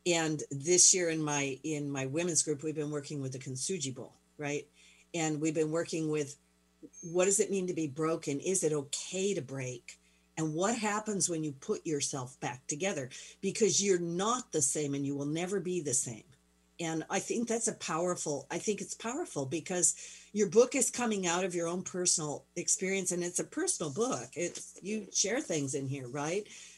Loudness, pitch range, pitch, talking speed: -32 LUFS, 145-190 Hz, 165 Hz, 195 wpm